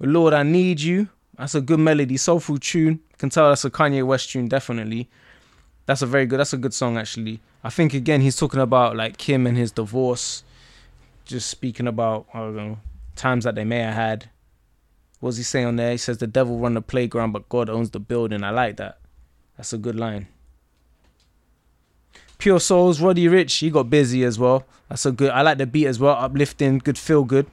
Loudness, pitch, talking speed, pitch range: -20 LUFS, 125 Hz, 210 wpm, 115-140 Hz